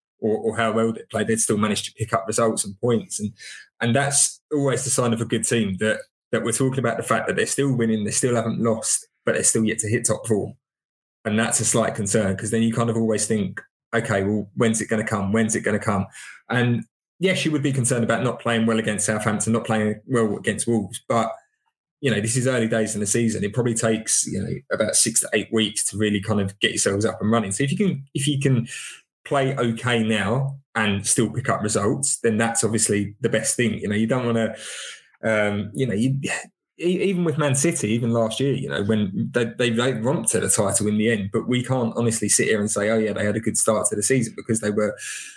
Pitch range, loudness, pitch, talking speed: 105-125 Hz, -22 LUFS, 115 Hz, 250 wpm